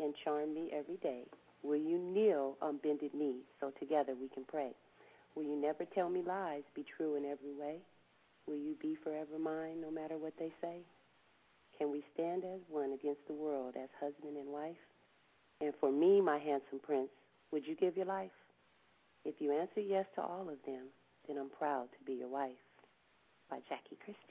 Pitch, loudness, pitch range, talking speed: 150 Hz, -40 LUFS, 145-165 Hz, 195 wpm